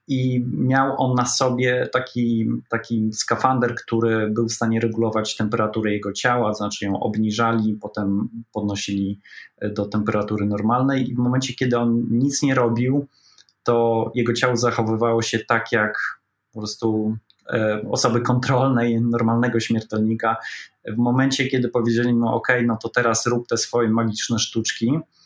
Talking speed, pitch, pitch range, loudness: 145 wpm, 115 Hz, 110-125 Hz, -21 LUFS